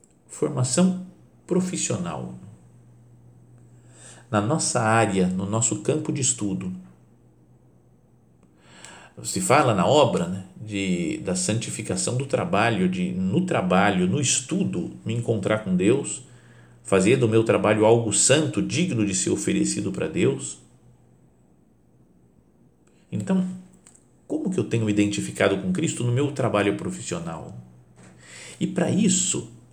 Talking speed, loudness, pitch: 115 wpm, -23 LUFS, 105 Hz